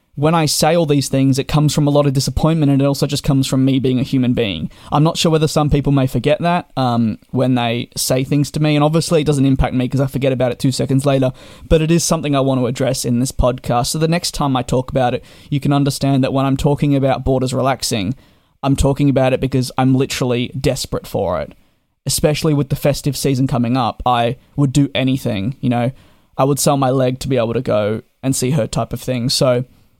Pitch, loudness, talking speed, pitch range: 135 Hz, -16 LUFS, 245 wpm, 125-145 Hz